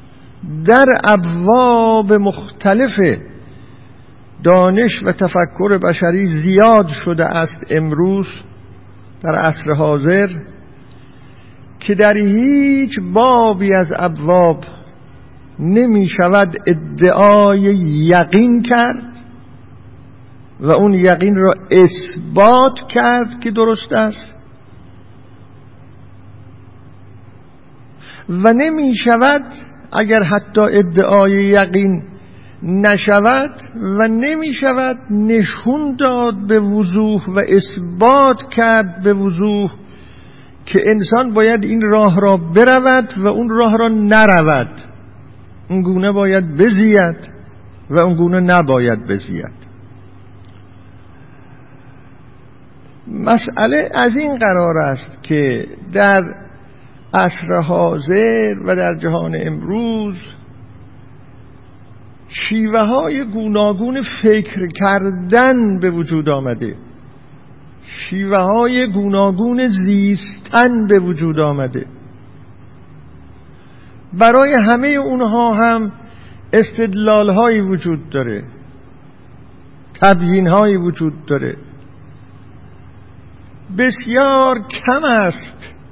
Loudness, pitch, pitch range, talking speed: -13 LUFS, 185 Hz, 130-220 Hz, 80 wpm